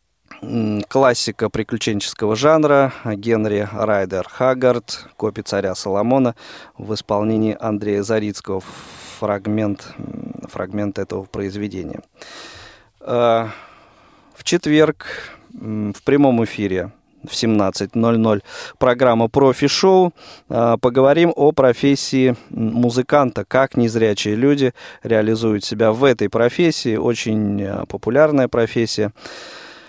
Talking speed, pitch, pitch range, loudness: 85 wpm, 115 Hz, 105-130 Hz, -18 LUFS